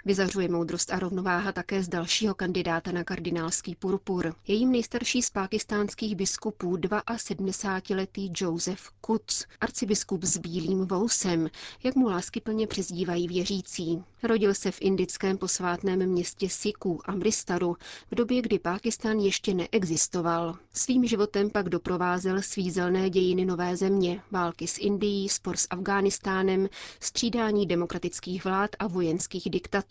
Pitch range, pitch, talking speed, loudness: 180-205 Hz, 190 Hz, 125 wpm, -28 LUFS